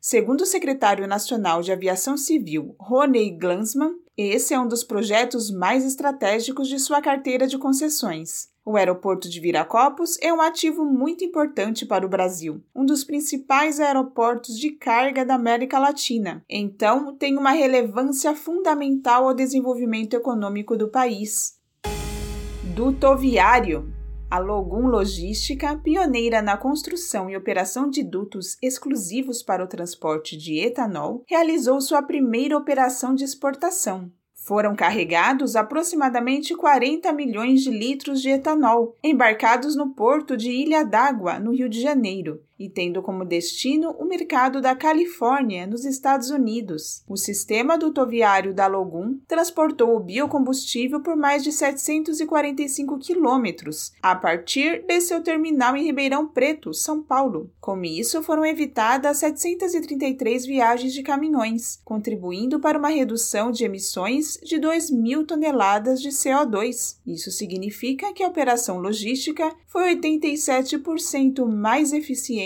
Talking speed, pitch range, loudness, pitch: 130 wpm, 215-295 Hz, -22 LUFS, 260 Hz